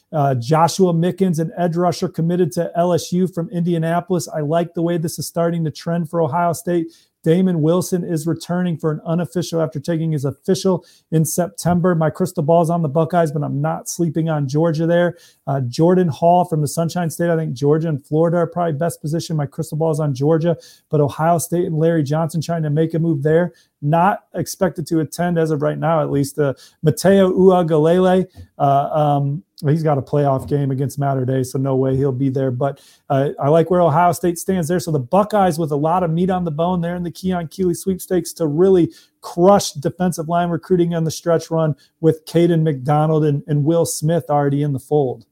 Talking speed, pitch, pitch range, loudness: 210 wpm, 165 Hz, 150-175 Hz, -18 LUFS